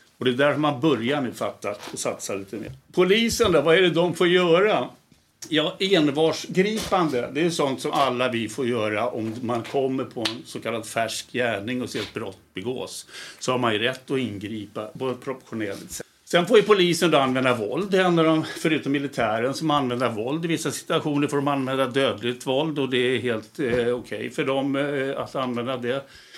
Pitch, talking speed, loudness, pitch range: 135 Hz, 205 wpm, -23 LUFS, 120-160 Hz